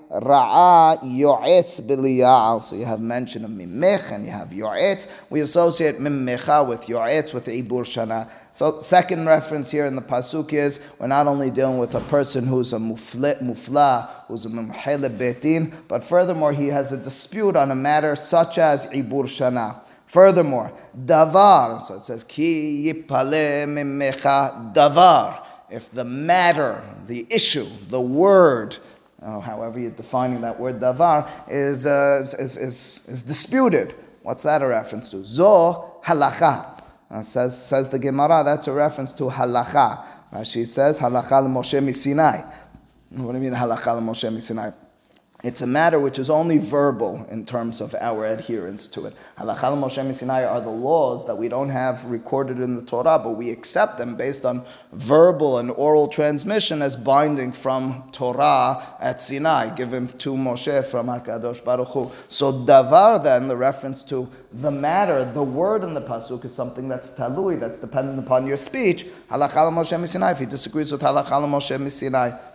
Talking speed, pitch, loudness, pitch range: 160 wpm, 135 Hz, -20 LUFS, 125-150 Hz